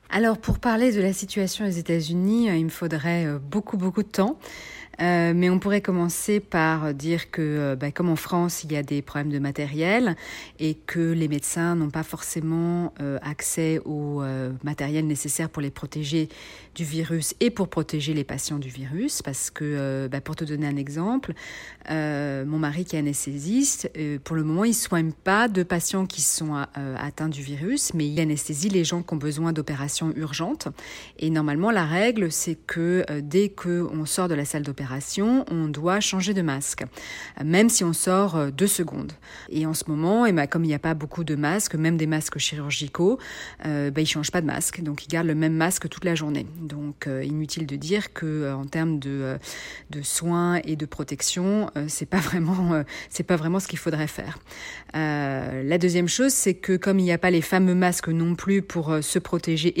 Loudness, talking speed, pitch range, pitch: -25 LUFS, 210 wpm, 150-180 Hz, 160 Hz